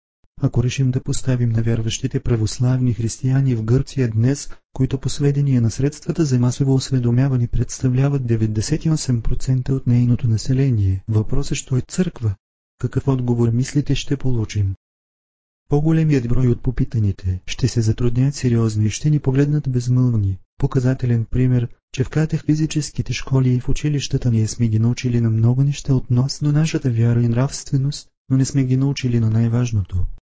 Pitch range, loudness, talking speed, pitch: 115-135 Hz, -19 LUFS, 145 wpm, 125 Hz